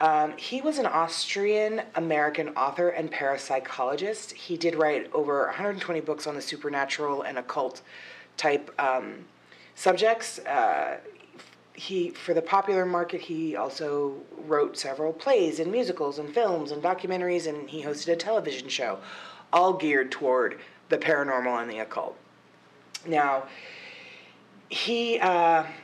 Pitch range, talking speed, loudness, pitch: 145-195 Hz, 130 wpm, -27 LUFS, 160 Hz